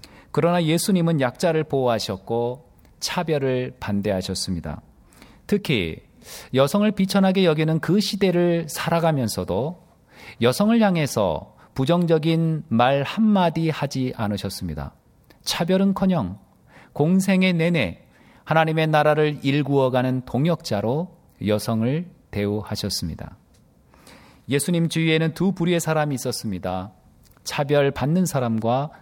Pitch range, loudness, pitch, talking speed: 115-170 Hz, -22 LUFS, 150 Hz, 270 characters per minute